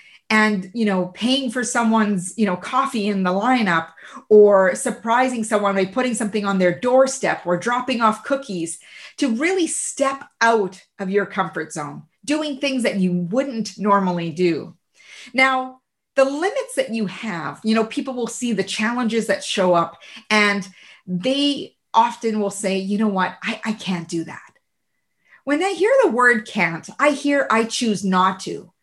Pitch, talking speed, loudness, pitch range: 220 Hz, 170 wpm, -20 LUFS, 190-255 Hz